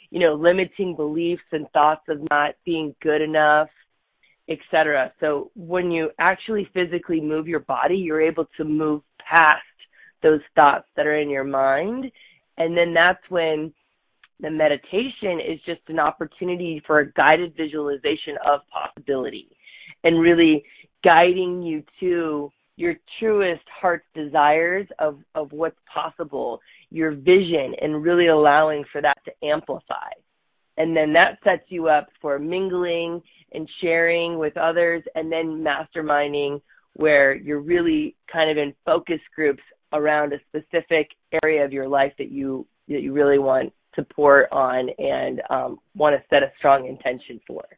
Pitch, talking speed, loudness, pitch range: 155 Hz, 150 wpm, -21 LUFS, 150-170 Hz